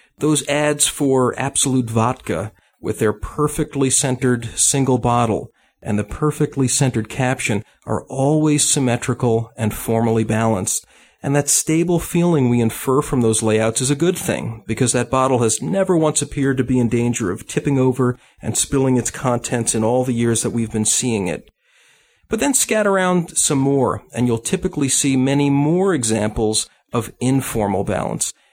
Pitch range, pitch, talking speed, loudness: 115-145 Hz, 130 Hz, 165 wpm, -18 LUFS